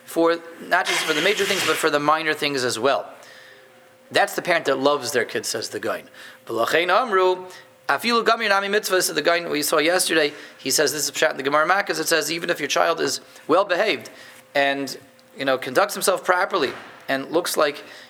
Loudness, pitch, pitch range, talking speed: -21 LUFS, 165 Hz, 145-185 Hz, 195 wpm